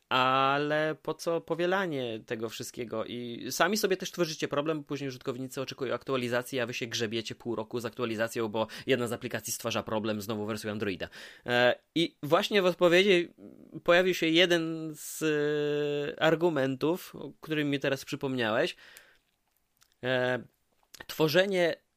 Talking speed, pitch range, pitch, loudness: 130 wpm, 120-160 Hz, 135 Hz, -29 LUFS